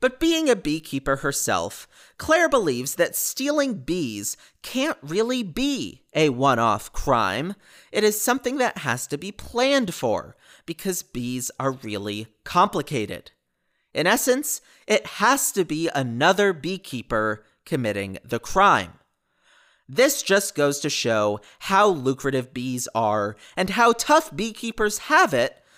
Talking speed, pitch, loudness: 135 wpm, 170 Hz, -23 LUFS